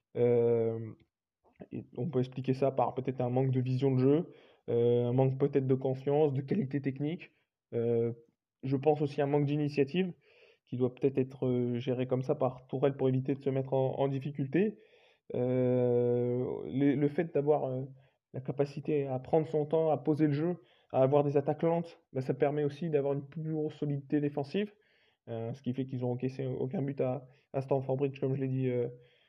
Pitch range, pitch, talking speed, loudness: 130-150 Hz, 135 Hz, 200 wpm, -32 LUFS